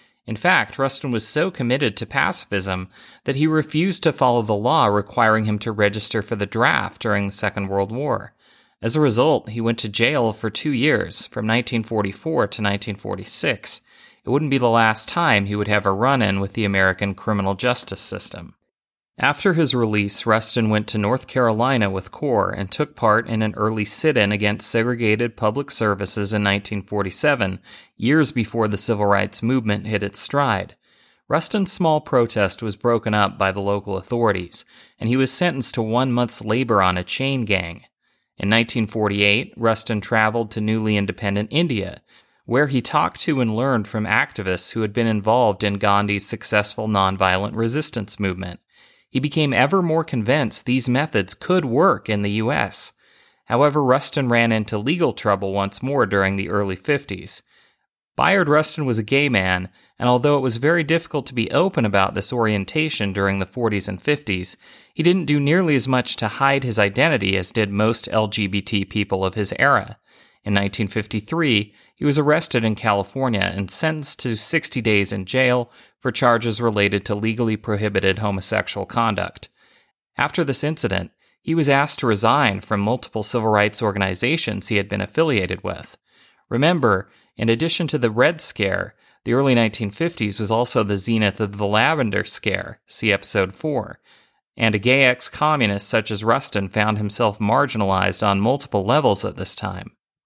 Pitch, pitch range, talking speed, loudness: 110 Hz, 100-130 Hz, 170 wpm, -19 LUFS